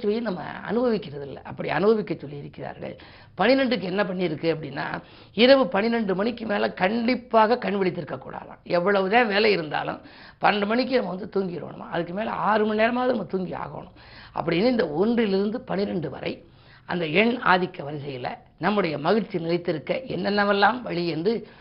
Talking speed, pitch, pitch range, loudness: 140 wpm, 200 Hz, 175-220 Hz, -24 LUFS